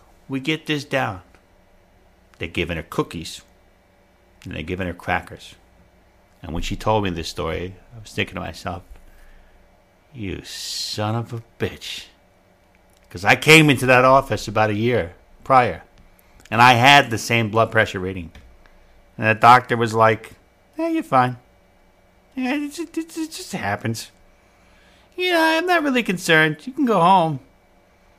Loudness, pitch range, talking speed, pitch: -19 LUFS, 95-130 Hz, 145 wpm, 100 Hz